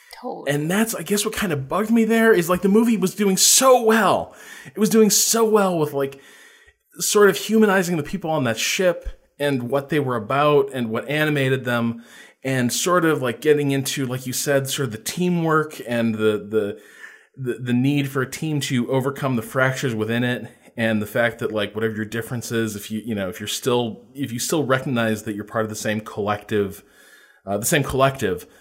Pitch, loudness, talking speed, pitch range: 135 Hz, -20 LUFS, 210 wpm, 115-180 Hz